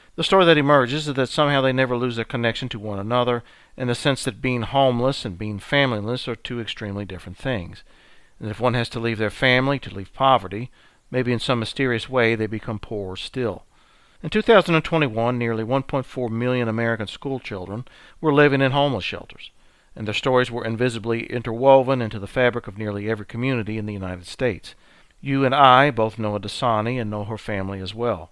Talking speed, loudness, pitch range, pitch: 195 wpm, -21 LUFS, 110-135 Hz, 120 Hz